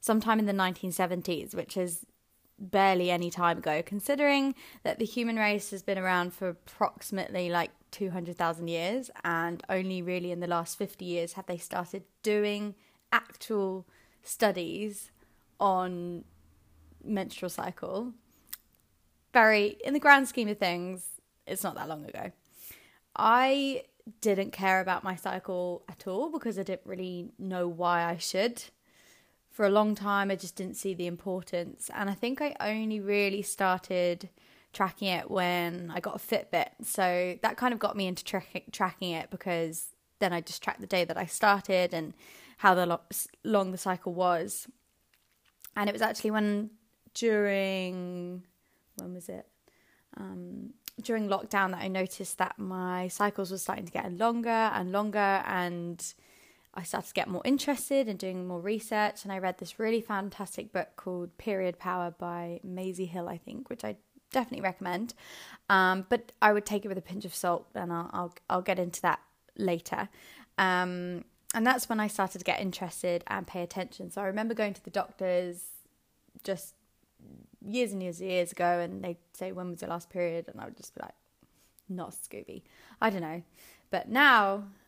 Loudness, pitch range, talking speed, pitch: -31 LUFS, 180-210 Hz, 170 wpm, 190 Hz